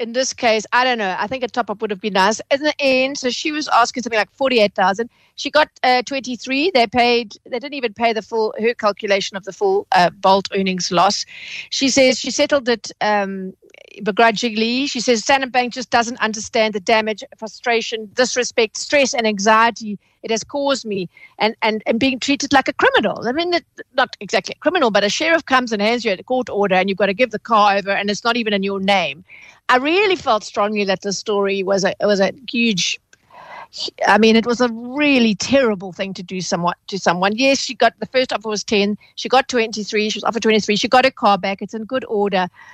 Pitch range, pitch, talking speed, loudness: 205-255 Hz, 225 Hz, 230 wpm, -18 LUFS